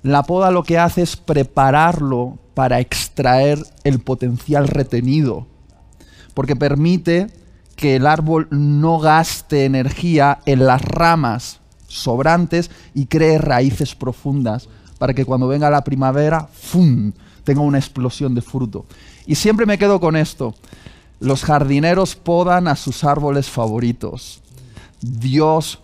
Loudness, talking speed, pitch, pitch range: -16 LUFS, 125 wpm, 140 Hz, 125-155 Hz